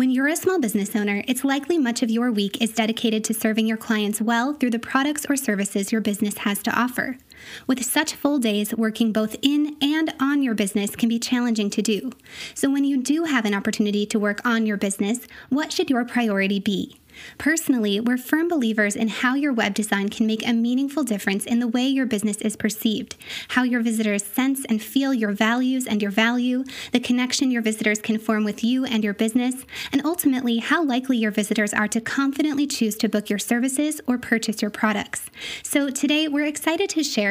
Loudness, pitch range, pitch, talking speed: -22 LUFS, 215-270 Hz, 235 Hz, 210 wpm